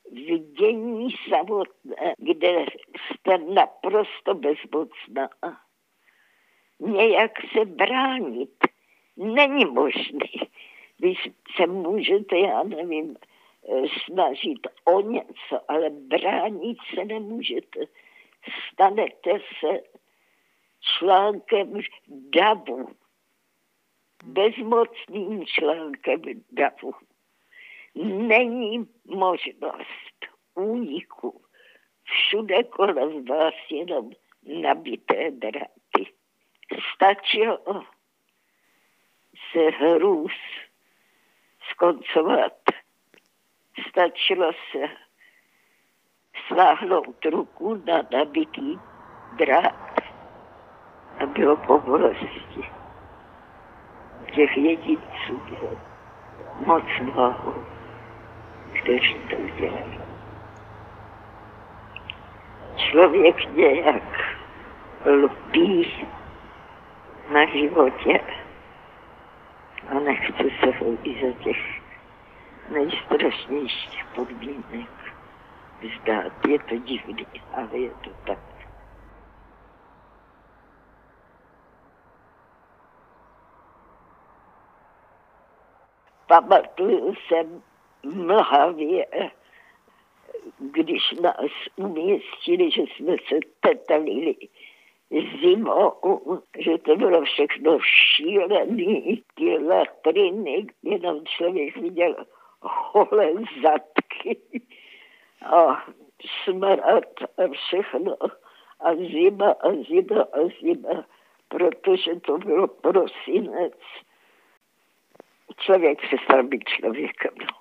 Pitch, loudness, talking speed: 235 Hz, -22 LUFS, 65 wpm